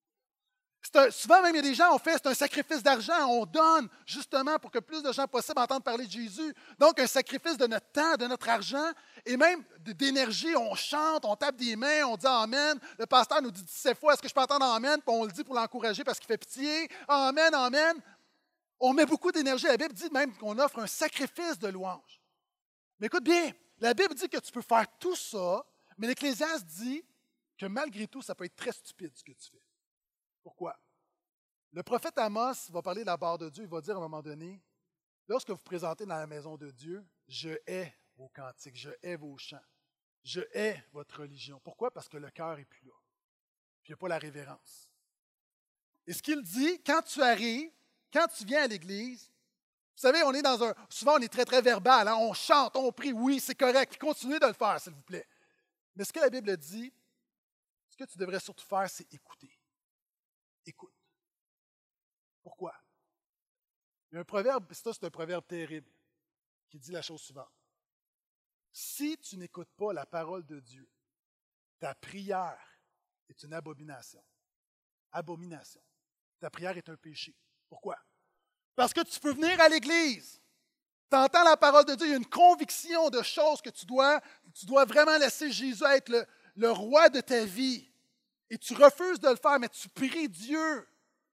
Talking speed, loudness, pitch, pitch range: 200 wpm, -28 LUFS, 250 Hz, 185-300 Hz